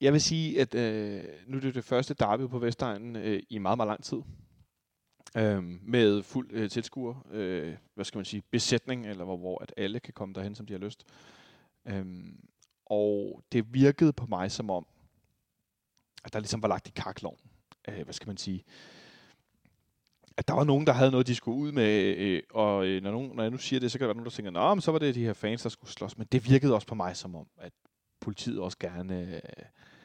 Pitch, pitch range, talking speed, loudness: 110 Hz, 100-130 Hz, 220 wpm, -30 LUFS